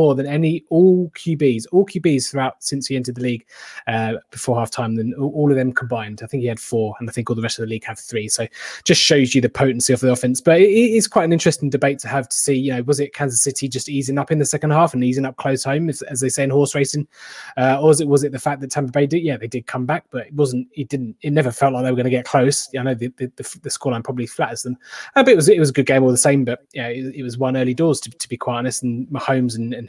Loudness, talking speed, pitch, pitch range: -18 LUFS, 305 wpm, 135 Hz, 125-145 Hz